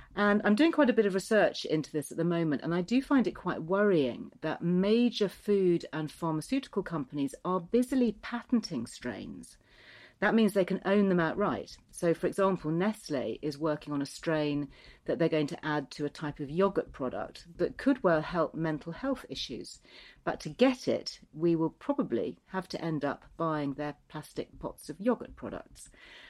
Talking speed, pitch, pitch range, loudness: 185 wpm, 170 Hz, 155-205 Hz, -31 LUFS